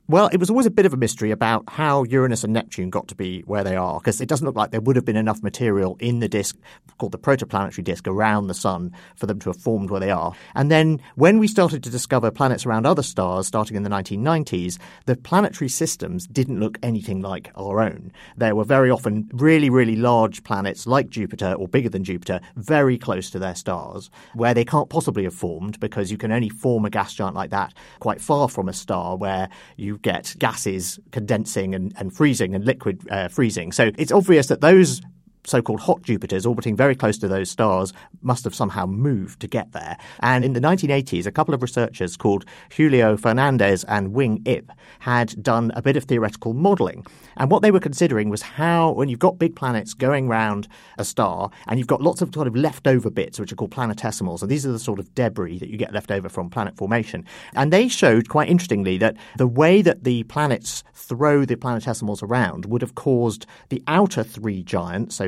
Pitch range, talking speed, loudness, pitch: 100-140 Hz, 215 wpm, -21 LUFS, 115 Hz